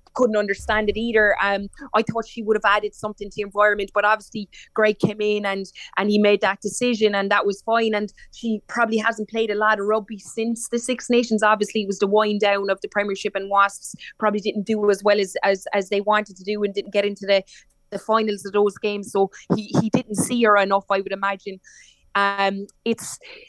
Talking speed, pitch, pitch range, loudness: 225 wpm, 210 Hz, 200-220 Hz, -21 LUFS